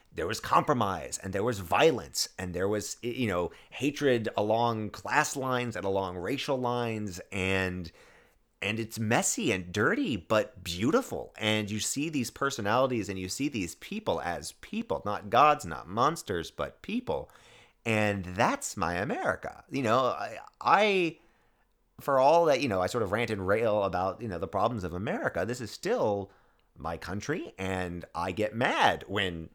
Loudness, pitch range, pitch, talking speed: -29 LUFS, 95-130 Hz, 110 Hz, 165 wpm